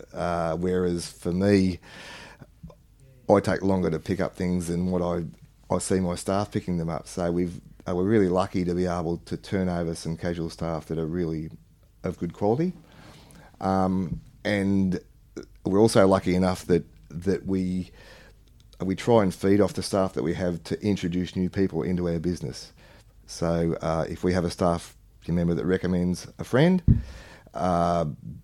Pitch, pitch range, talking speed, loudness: 90 Hz, 85-95 Hz, 170 wpm, -26 LUFS